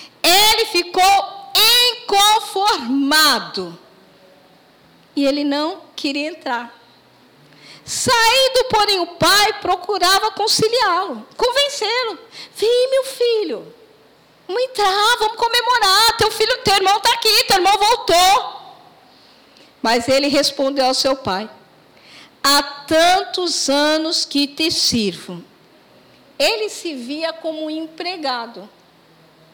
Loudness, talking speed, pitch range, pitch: -16 LUFS, 100 wpm, 285-430 Hz, 360 Hz